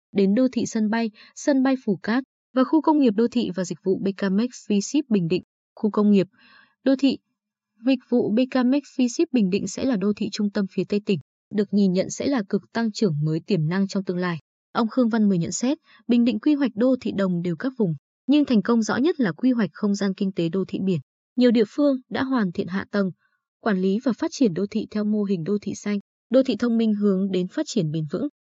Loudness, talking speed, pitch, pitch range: -23 LUFS, 250 wpm, 215 Hz, 195-255 Hz